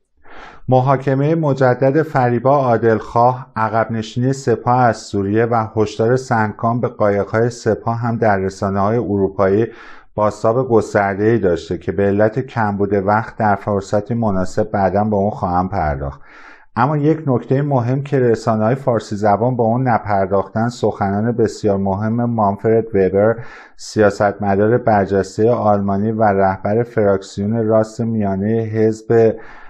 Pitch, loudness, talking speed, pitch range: 110 Hz, -17 LUFS, 130 wpm, 100-120 Hz